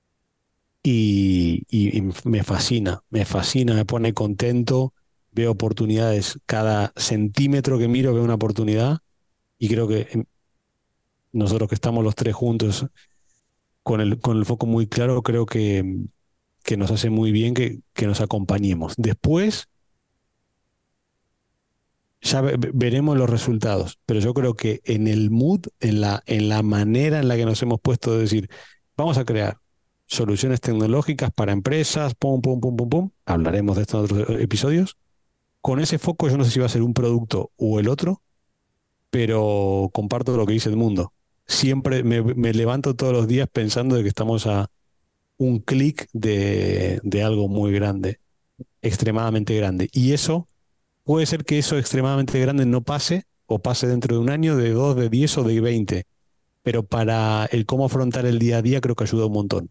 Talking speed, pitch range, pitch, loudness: 170 wpm, 105-130 Hz, 115 Hz, -21 LUFS